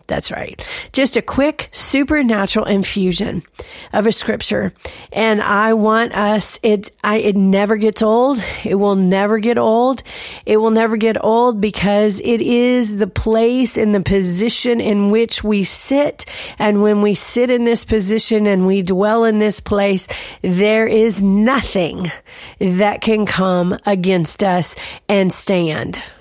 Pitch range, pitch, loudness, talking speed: 200-225 Hz, 215 Hz, -15 LUFS, 150 wpm